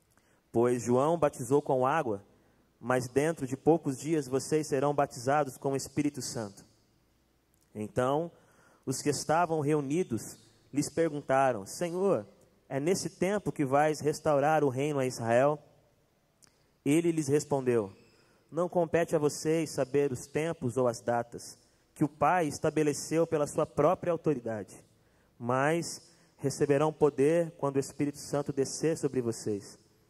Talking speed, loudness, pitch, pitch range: 130 wpm, -30 LUFS, 145 Hz, 130-155 Hz